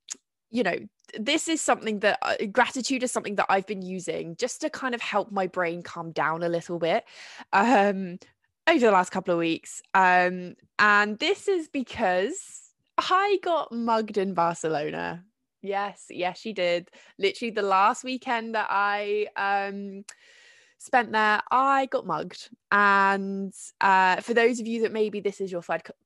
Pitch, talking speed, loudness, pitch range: 205 Hz, 165 wpm, -25 LUFS, 185-250 Hz